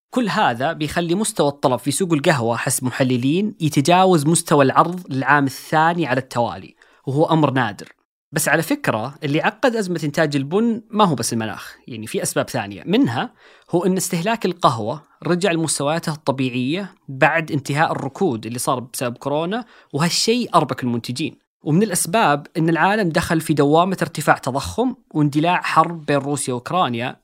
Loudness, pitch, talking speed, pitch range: -19 LUFS, 155 Hz, 150 wpm, 135-175 Hz